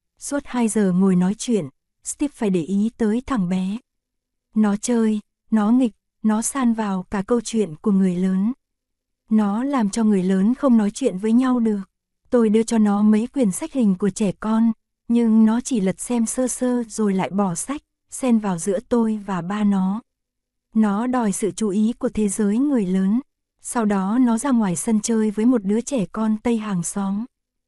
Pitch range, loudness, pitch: 200-240 Hz, -21 LUFS, 220 Hz